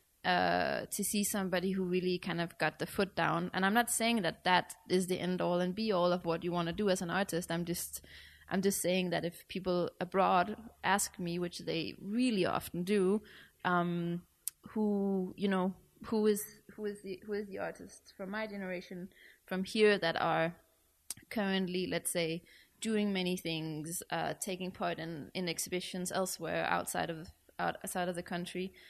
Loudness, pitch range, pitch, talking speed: -34 LUFS, 175-200 Hz, 185 Hz, 185 wpm